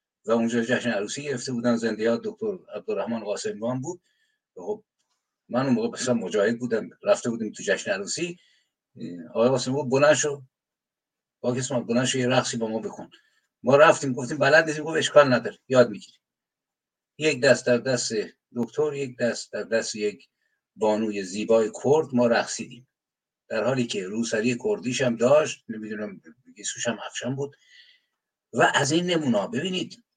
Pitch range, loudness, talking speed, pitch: 115-150 Hz, -24 LUFS, 145 wpm, 125 Hz